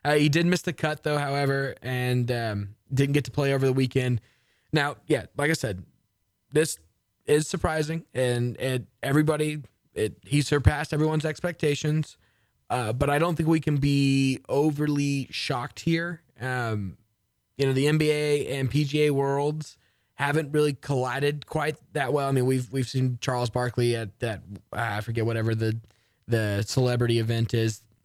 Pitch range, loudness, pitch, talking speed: 115-150 Hz, -26 LUFS, 135 Hz, 160 wpm